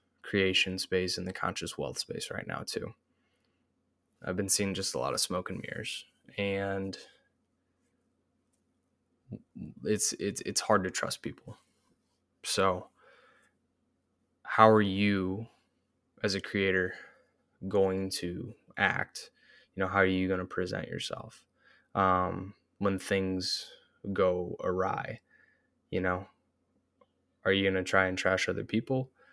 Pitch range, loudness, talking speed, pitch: 95-100 Hz, -31 LUFS, 125 wpm, 95 Hz